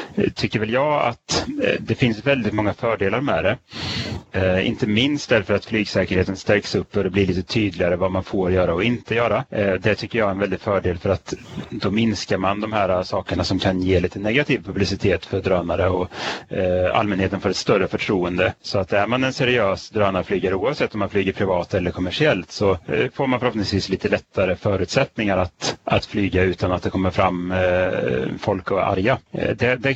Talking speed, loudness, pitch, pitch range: 185 wpm, -21 LUFS, 100 Hz, 95-110 Hz